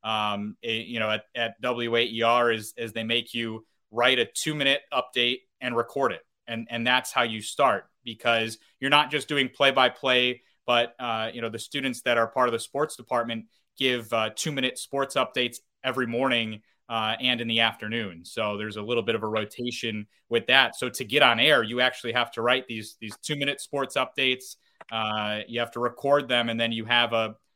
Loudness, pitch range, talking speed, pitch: -25 LUFS, 115-130 Hz, 210 wpm, 120 Hz